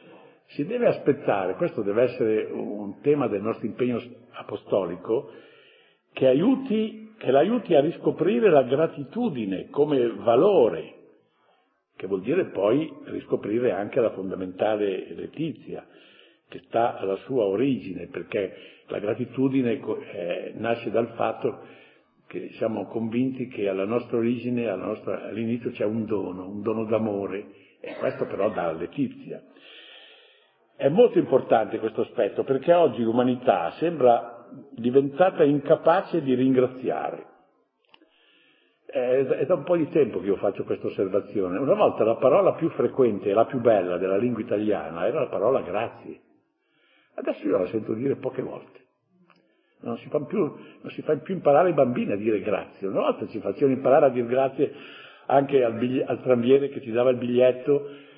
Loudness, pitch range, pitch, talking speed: -24 LUFS, 115-175 Hz, 130 Hz, 145 wpm